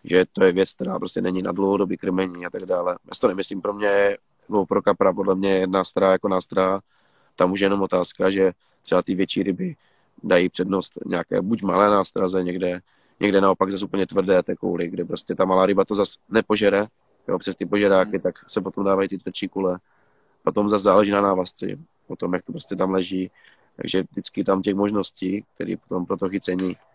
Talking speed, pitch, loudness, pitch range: 205 wpm, 95 Hz, -22 LUFS, 95-100 Hz